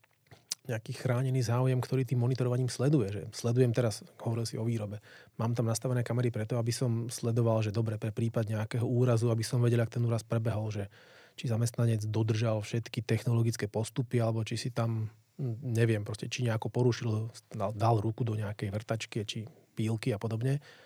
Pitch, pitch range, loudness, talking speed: 115 Hz, 110-125 Hz, -32 LUFS, 175 wpm